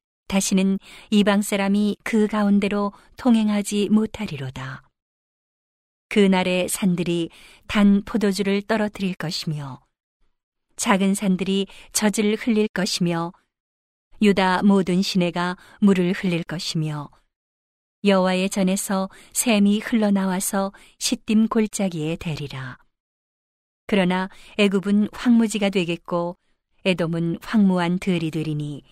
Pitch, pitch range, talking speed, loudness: 195 Hz, 175-205 Hz, 235 characters per minute, -22 LUFS